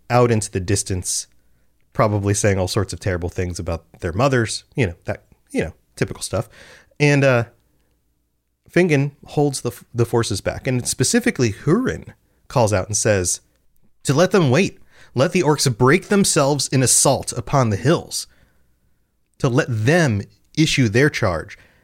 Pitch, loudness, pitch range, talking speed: 115 Hz, -19 LUFS, 95-140 Hz, 155 wpm